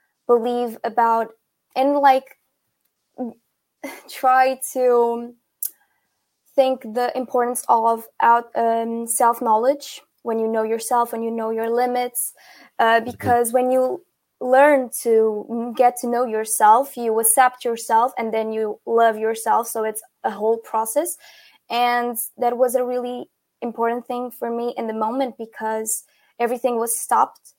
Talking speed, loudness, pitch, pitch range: 135 wpm, -20 LUFS, 240 Hz, 225-250 Hz